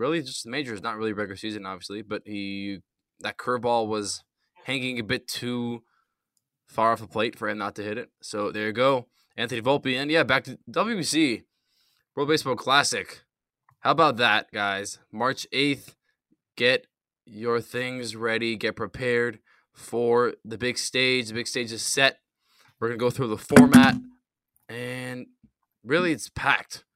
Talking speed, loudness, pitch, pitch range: 165 wpm, -25 LUFS, 120 Hz, 110-130 Hz